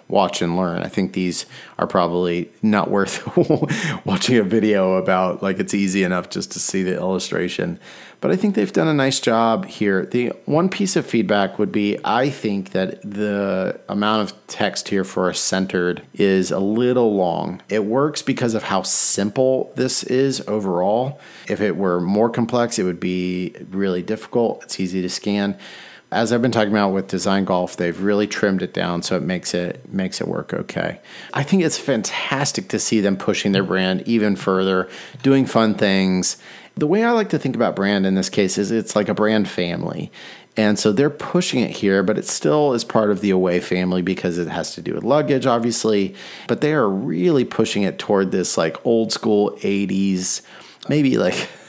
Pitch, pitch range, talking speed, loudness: 100 Hz, 95-115 Hz, 195 wpm, -20 LUFS